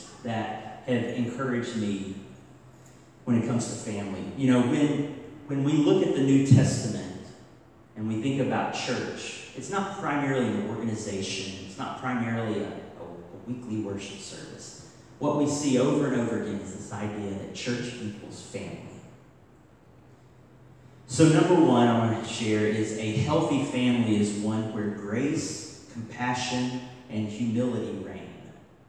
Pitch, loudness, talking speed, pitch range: 115 Hz, -27 LUFS, 145 wpm, 105-130 Hz